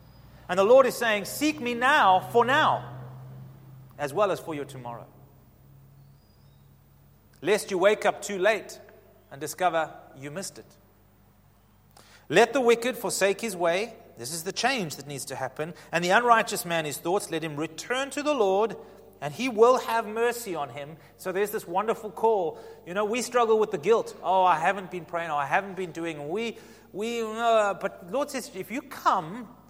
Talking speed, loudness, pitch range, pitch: 185 wpm, -26 LUFS, 140-230 Hz, 185 Hz